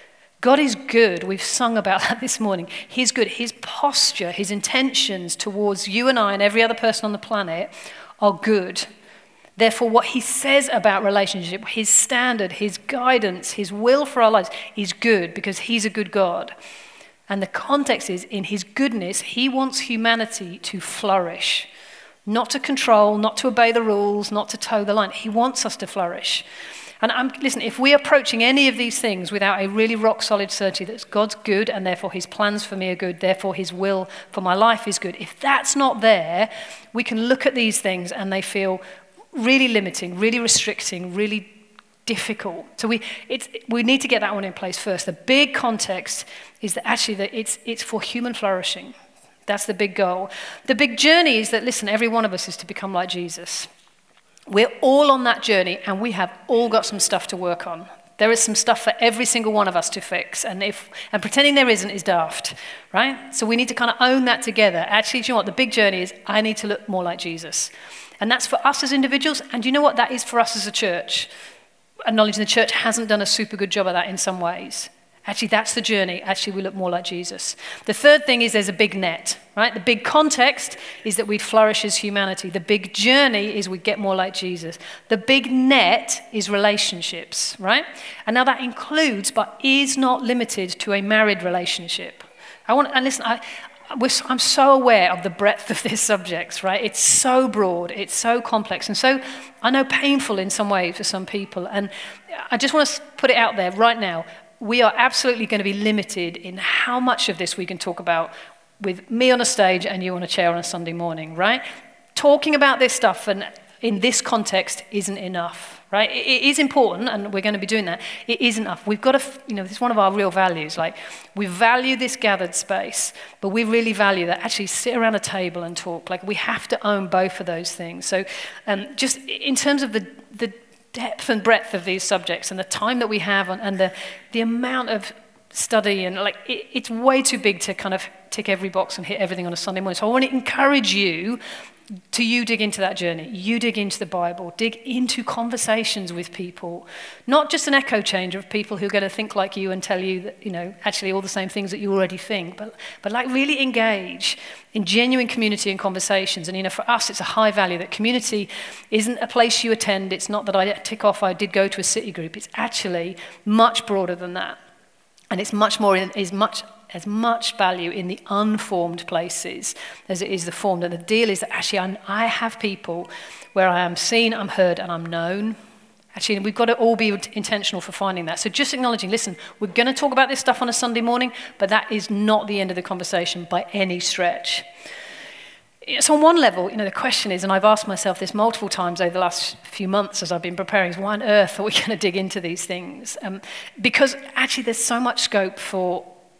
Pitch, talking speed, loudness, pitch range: 210 Hz, 225 wpm, -20 LUFS, 190-235 Hz